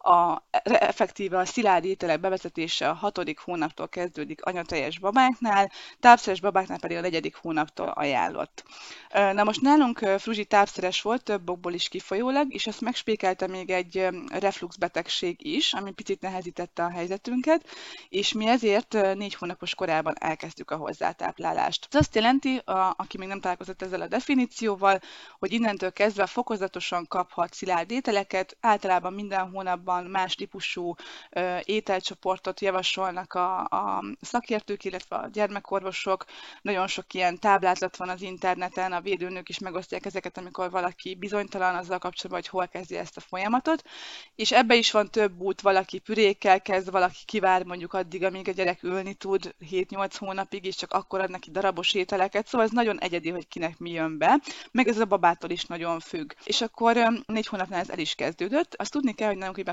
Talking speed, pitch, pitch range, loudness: 160 wpm, 190 Hz, 180-215 Hz, -27 LUFS